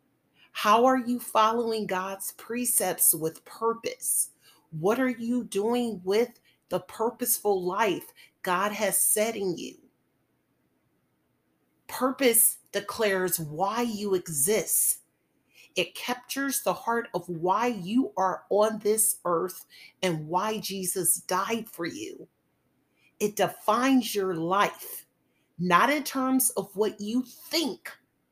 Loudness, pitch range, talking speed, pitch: -26 LUFS, 185-240 Hz, 115 wpm, 215 Hz